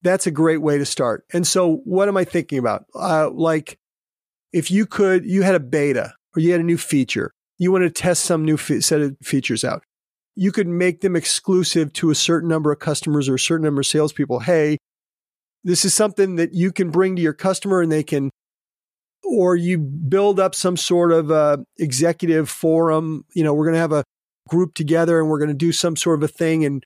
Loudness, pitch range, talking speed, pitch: -19 LUFS, 150-180 Hz, 220 wpm, 165 Hz